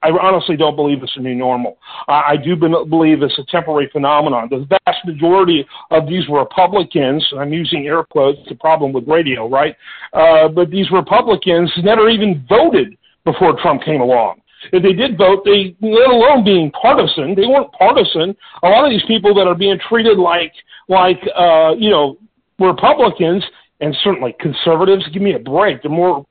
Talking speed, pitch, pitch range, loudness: 180 wpm, 175 Hz, 150-195 Hz, -13 LUFS